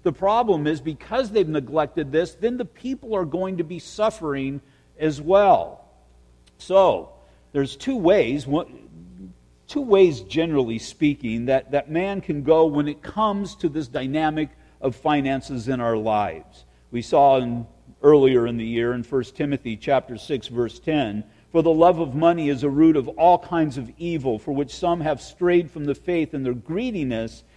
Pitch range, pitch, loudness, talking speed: 125-170 Hz, 150 Hz, -22 LUFS, 170 wpm